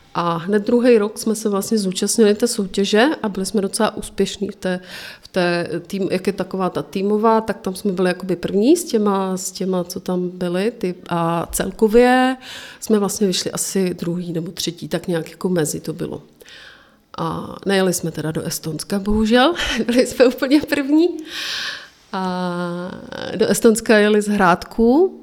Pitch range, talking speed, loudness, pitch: 180-225 Hz, 170 wpm, -19 LUFS, 200 Hz